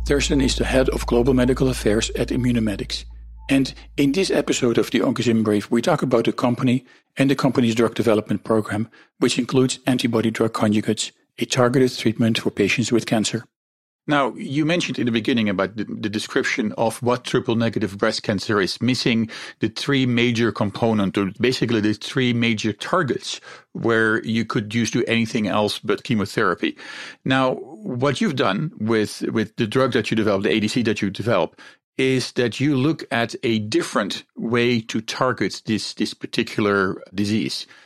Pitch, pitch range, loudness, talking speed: 115 Hz, 110-125 Hz, -21 LUFS, 170 wpm